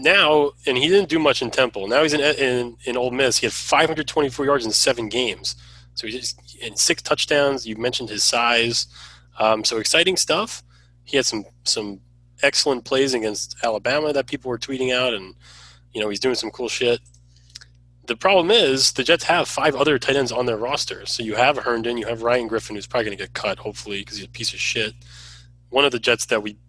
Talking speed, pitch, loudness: 220 wpm, 115 Hz, -20 LUFS